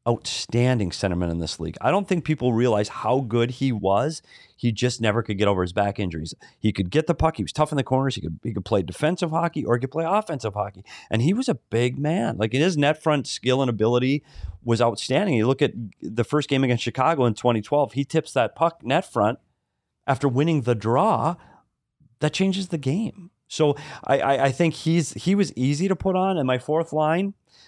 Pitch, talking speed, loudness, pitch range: 130 Hz, 220 wpm, -23 LUFS, 115-155 Hz